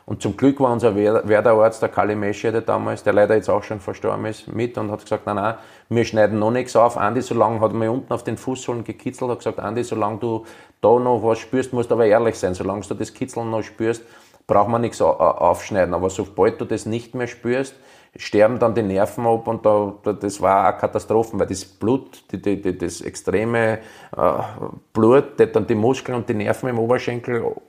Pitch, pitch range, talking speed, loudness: 115 Hz, 105-120 Hz, 205 wpm, -20 LUFS